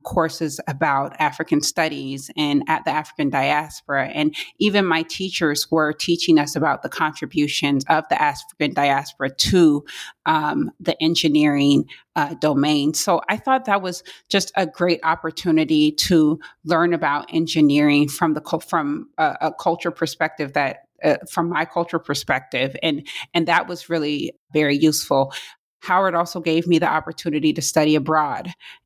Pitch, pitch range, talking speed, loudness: 160 Hz, 150-170 Hz, 150 wpm, -20 LUFS